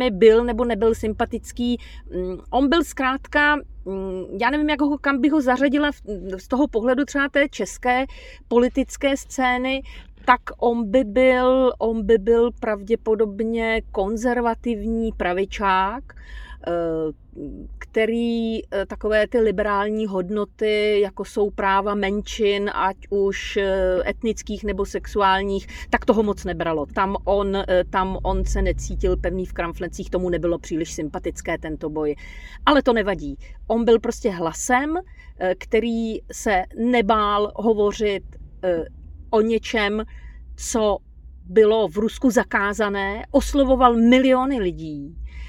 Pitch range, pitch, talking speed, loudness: 190-240 Hz, 215 Hz, 115 wpm, -21 LUFS